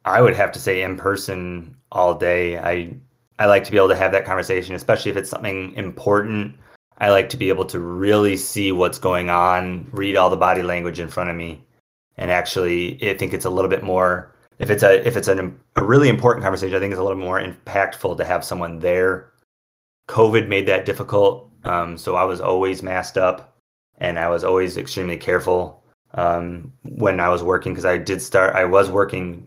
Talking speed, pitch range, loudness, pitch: 210 wpm, 90-100 Hz, -19 LUFS, 95 Hz